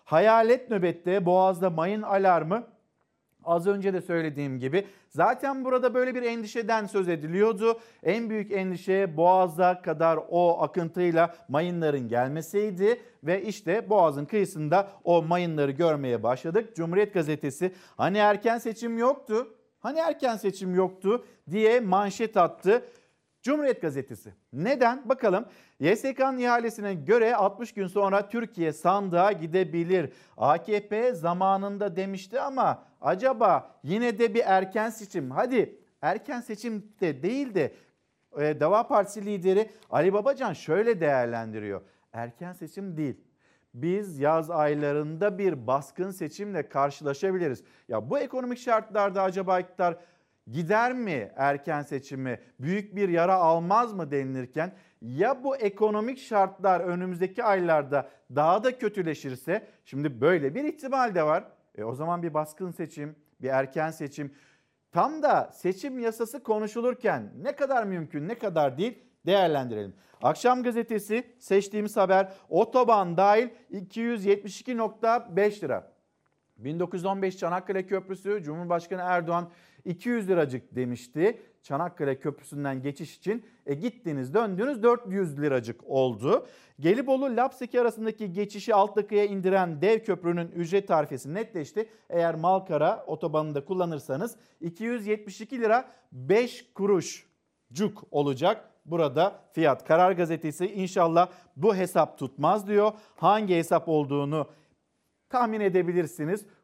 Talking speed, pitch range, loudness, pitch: 115 wpm, 160-220 Hz, -27 LUFS, 190 Hz